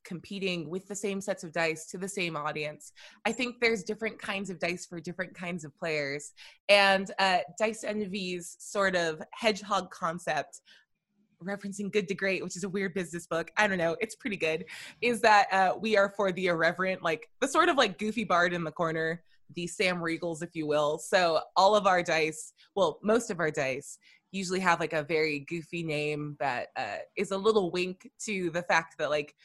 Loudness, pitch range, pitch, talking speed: -29 LUFS, 165-205 Hz, 185 Hz, 200 wpm